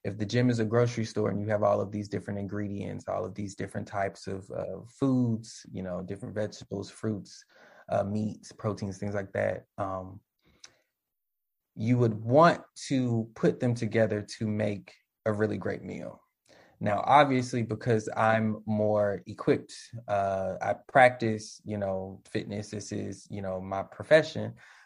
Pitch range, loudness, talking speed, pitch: 100-115 Hz, -29 LUFS, 160 wpm, 105 Hz